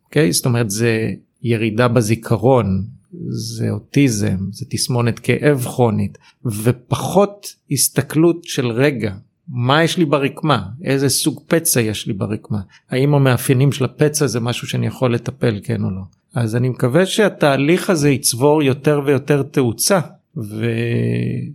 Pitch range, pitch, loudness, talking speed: 115-145 Hz, 130 Hz, -17 LUFS, 135 wpm